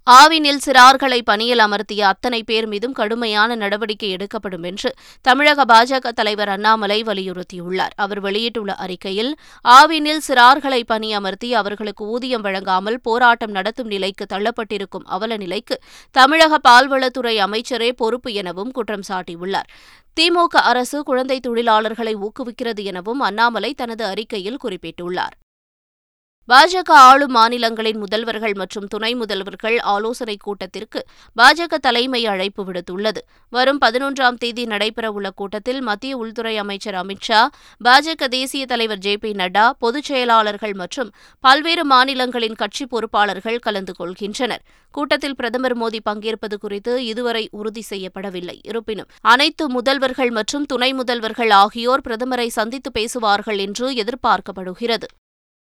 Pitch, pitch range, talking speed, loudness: 225 Hz, 205-250 Hz, 115 wpm, -17 LUFS